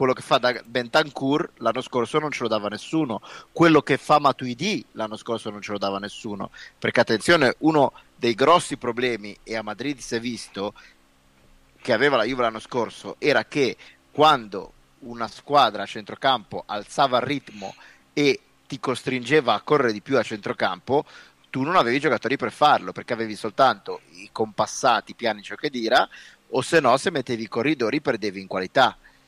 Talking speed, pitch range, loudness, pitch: 175 wpm, 105-140 Hz, -23 LUFS, 120 Hz